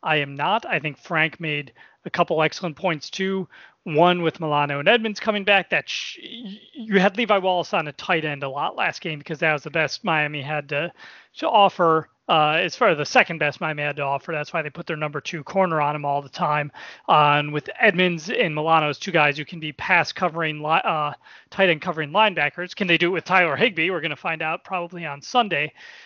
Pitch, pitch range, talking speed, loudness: 165 Hz, 150-185 Hz, 235 wpm, -22 LUFS